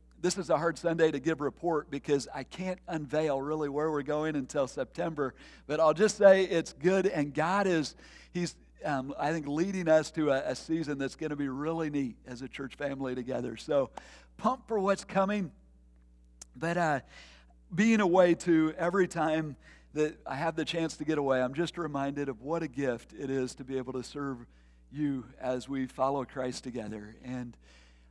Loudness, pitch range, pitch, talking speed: -31 LUFS, 130-165 Hz, 145 Hz, 190 wpm